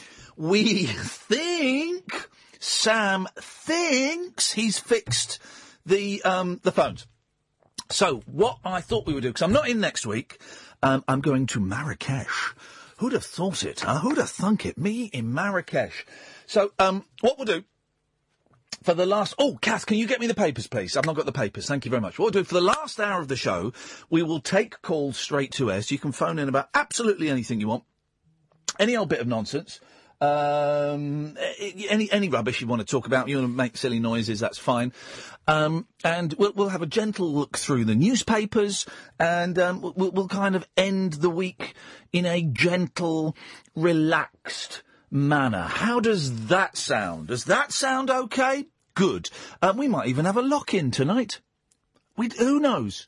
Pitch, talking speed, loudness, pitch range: 175 Hz, 180 wpm, -25 LUFS, 135-210 Hz